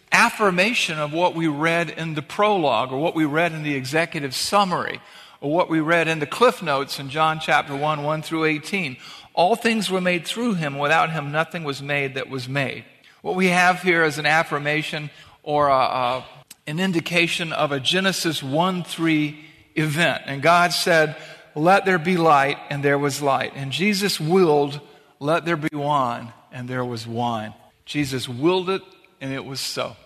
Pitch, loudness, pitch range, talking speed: 155 Hz, -21 LUFS, 145-175 Hz, 185 wpm